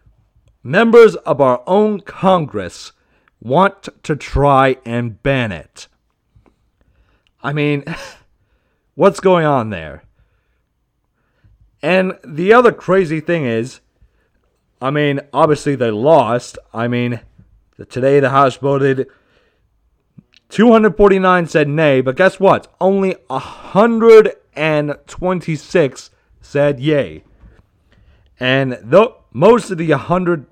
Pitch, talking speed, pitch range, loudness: 140 Hz, 100 wpm, 115-180 Hz, -14 LUFS